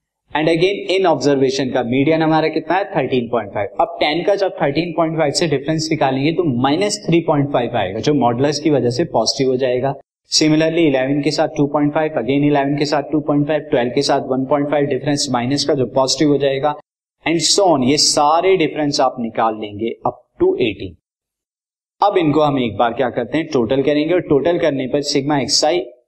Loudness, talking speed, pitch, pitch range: -16 LUFS, 190 wpm, 145 Hz, 130-160 Hz